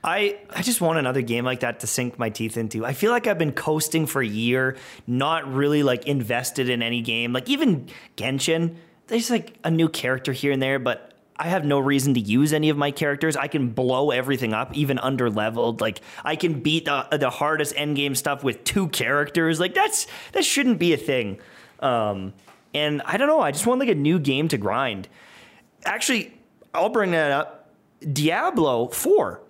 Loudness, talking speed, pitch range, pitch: -23 LUFS, 205 wpm, 130-165 Hz, 145 Hz